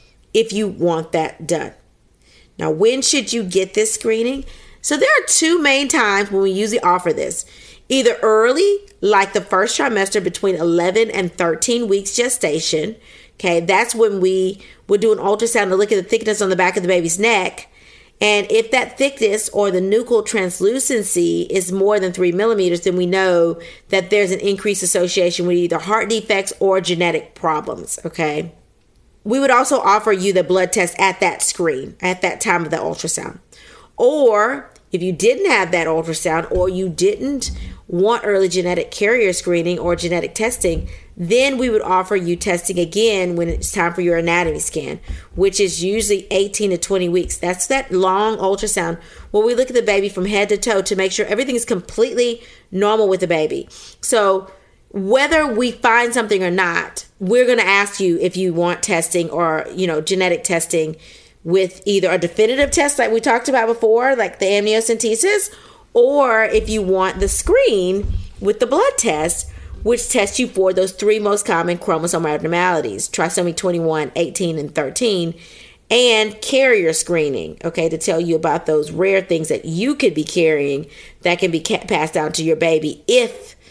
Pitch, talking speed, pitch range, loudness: 195 Hz, 180 wpm, 175-225 Hz, -17 LUFS